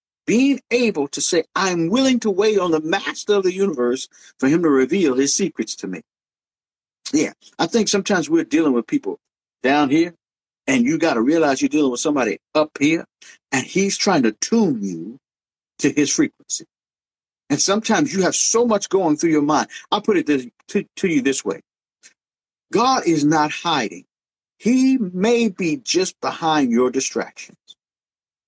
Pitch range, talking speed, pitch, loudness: 150-235 Hz, 175 wpm, 190 Hz, -19 LUFS